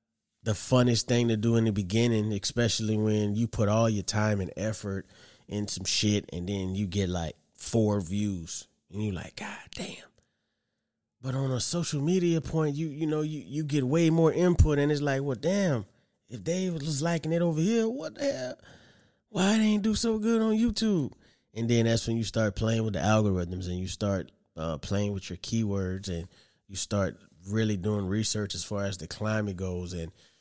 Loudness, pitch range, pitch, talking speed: -28 LUFS, 100-150 Hz, 110 Hz, 200 wpm